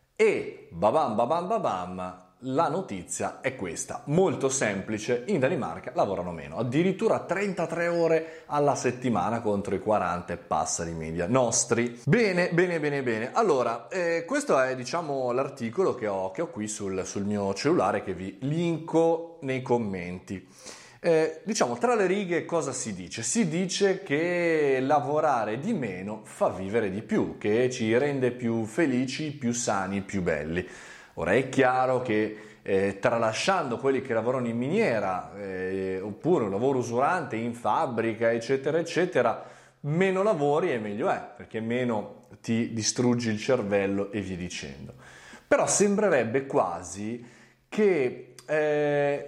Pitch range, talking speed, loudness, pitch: 110-165 Hz, 140 wpm, -27 LUFS, 130 Hz